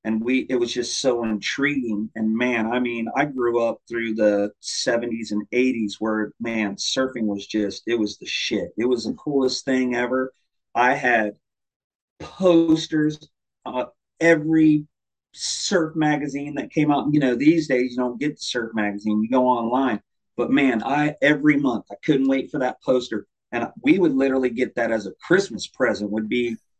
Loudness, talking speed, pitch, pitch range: -22 LUFS, 180 wpm, 125 Hz, 110-145 Hz